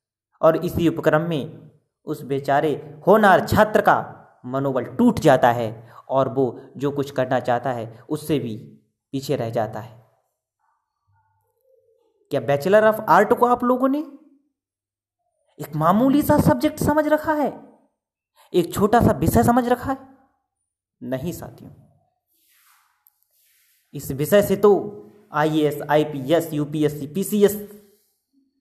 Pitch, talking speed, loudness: 155 Hz, 120 wpm, -20 LUFS